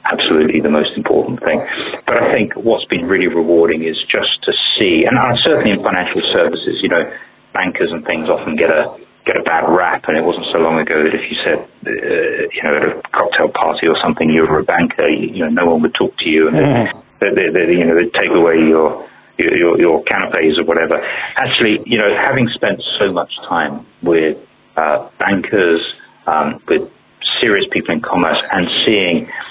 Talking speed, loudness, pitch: 205 wpm, -14 LUFS, 85 Hz